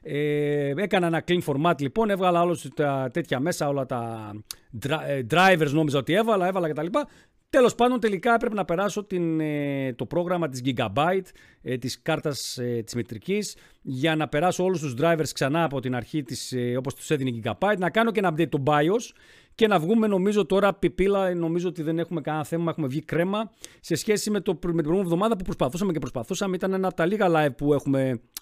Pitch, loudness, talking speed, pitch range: 165 Hz, -25 LUFS, 195 wpm, 140-190 Hz